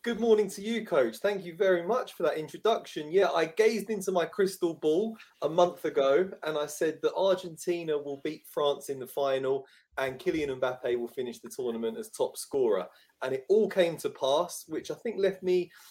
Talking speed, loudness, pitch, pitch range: 205 wpm, -30 LUFS, 180 Hz, 155-215 Hz